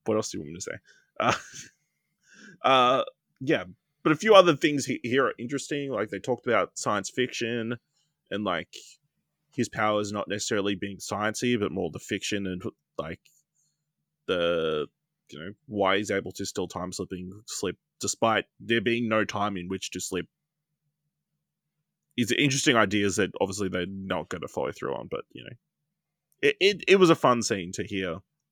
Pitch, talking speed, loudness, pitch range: 115 Hz, 175 wpm, -27 LUFS, 100-155 Hz